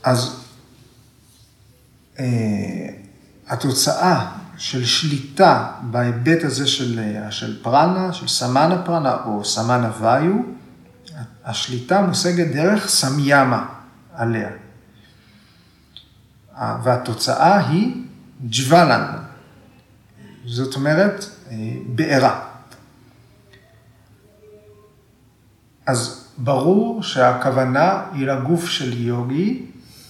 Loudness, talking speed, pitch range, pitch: -19 LUFS, 75 wpm, 115-145 Hz, 125 Hz